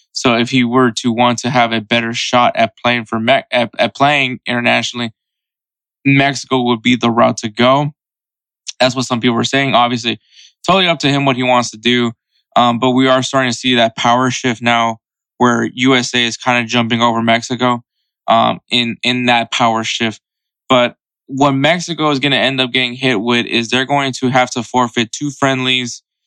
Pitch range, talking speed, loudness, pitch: 120-130 Hz, 200 wpm, -14 LUFS, 125 Hz